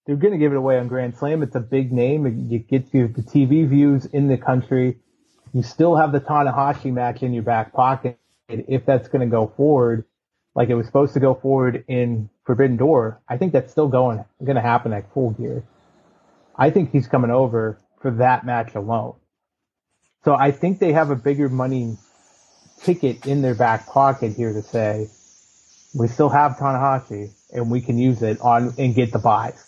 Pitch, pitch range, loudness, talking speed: 130 Hz, 120-140 Hz, -20 LUFS, 195 wpm